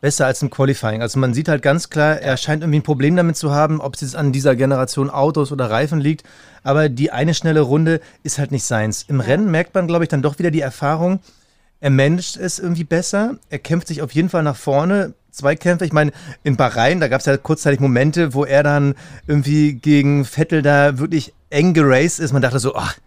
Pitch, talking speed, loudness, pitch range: 145 Hz, 235 wpm, -17 LUFS, 135-160 Hz